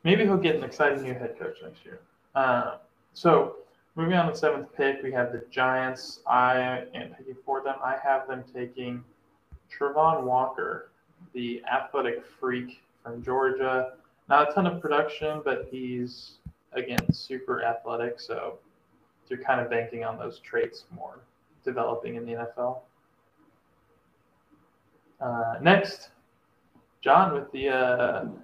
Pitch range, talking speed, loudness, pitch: 125-155 Hz, 140 wpm, -27 LUFS, 130 Hz